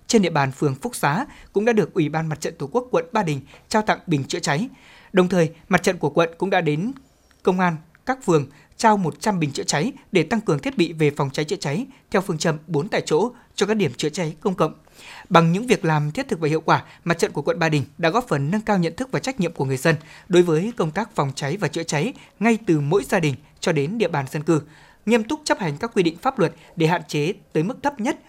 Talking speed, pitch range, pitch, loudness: 270 wpm, 155-210 Hz, 170 Hz, -22 LUFS